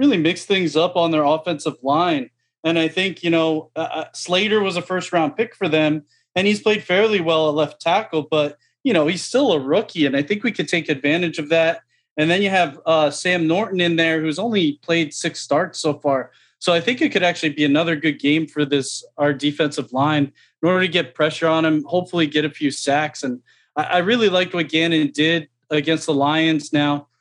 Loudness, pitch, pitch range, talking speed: -19 LUFS, 160 Hz, 150-180 Hz, 220 wpm